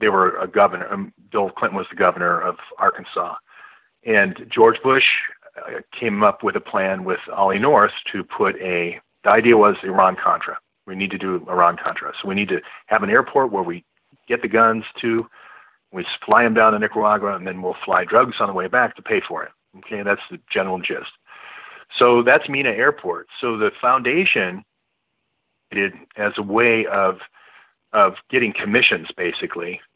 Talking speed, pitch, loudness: 180 wpm, 110 Hz, -19 LUFS